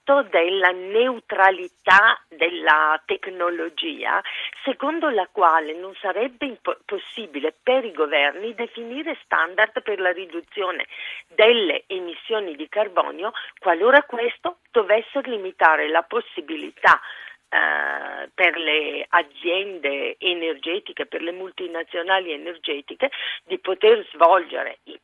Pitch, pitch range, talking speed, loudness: 200 Hz, 170-270 Hz, 100 wpm, -21 LUFS